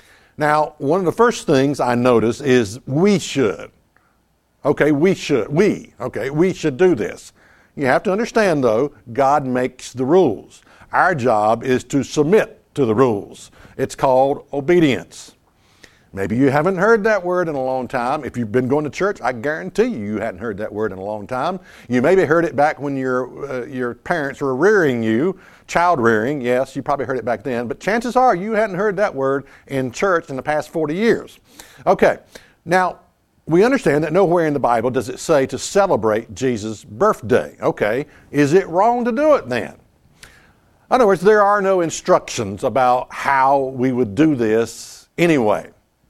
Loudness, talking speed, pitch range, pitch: -18 LUFS, 185 wpm, 125-180 Hz, 140 Hz